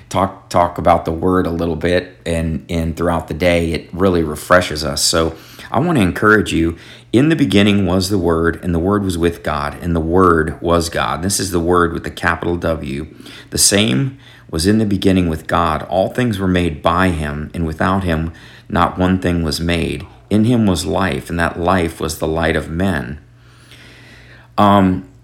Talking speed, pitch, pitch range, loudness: 195 wpm, 85 Hz, 80-95 Hz, -16 LUFS